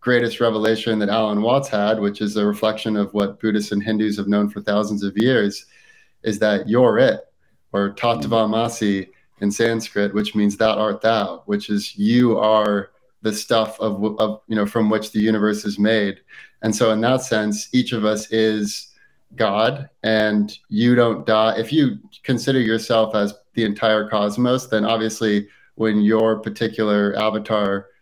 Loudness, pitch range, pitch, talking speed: -20 LUFS, 105-115 Hz, 110 Hz, 170 wpm